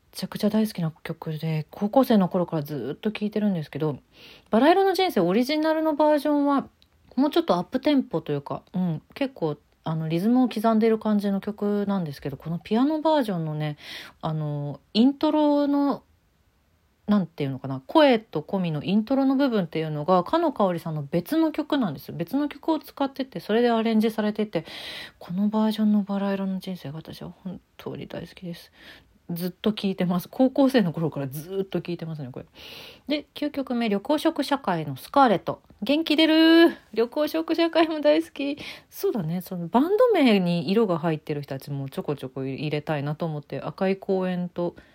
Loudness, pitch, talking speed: -24 LUFS, 200 Hz, 385 characters per minute